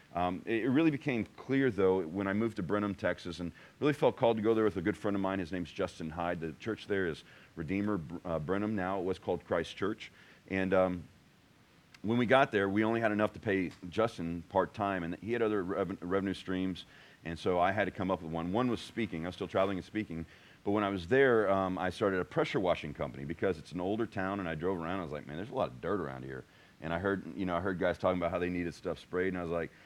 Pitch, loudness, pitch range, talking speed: 95 Hz, -33 LUFS, 85-105 Hz, 265 wpm